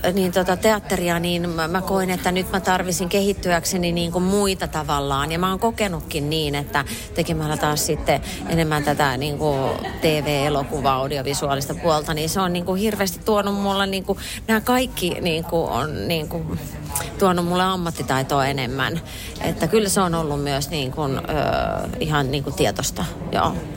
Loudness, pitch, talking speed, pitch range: -22 LUFS, 165 Hz, 145 wpm, 145-185 Hz